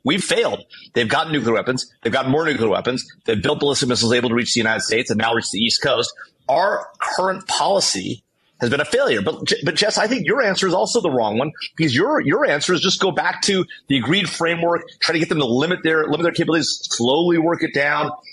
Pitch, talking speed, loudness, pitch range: 165 Hz, 235 wpm, -19 LUFS, 140-180 Hz